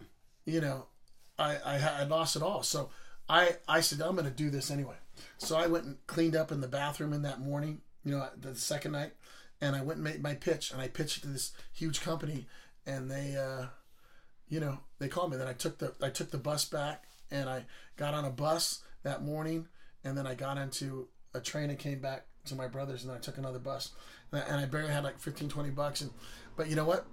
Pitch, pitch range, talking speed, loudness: 145 Hz, 135-155 Hz, 235 wpm, -35 LUFS